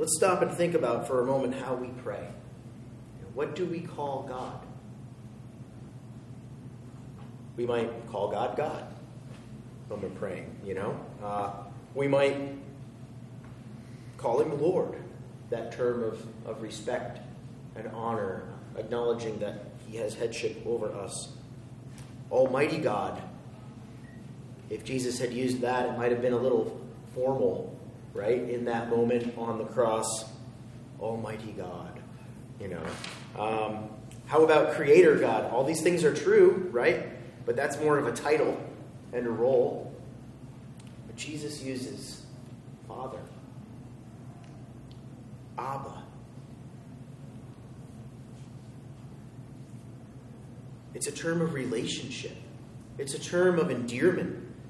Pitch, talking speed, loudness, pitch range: 125 Hz, 115 wpm, -30 LUFS, 120-130 Hz